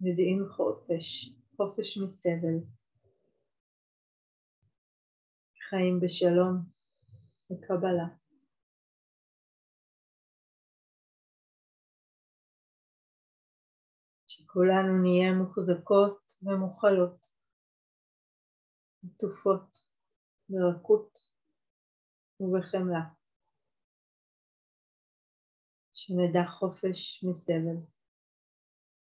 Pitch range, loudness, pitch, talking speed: 165-190 Hz, -29 LUFS, 180 Hz, 35 wpm